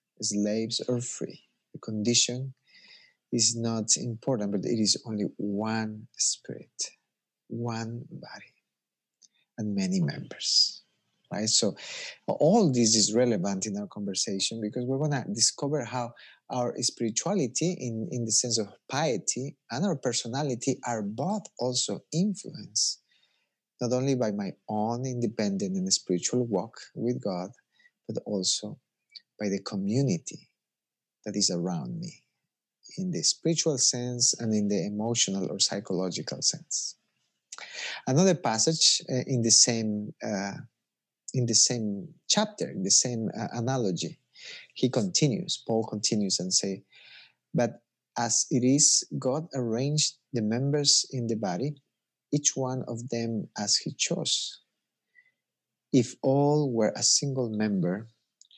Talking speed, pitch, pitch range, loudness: 130 wpm, 120 Hz, 110-145 Hz, -27 LUFS